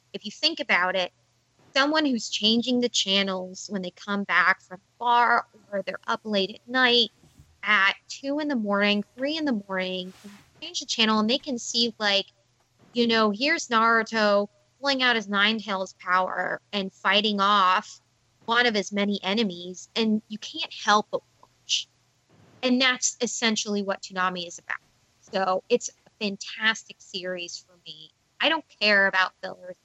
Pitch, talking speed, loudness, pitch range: 205 Hz, 165 wpm, -24 LUFS, 185-235 Hz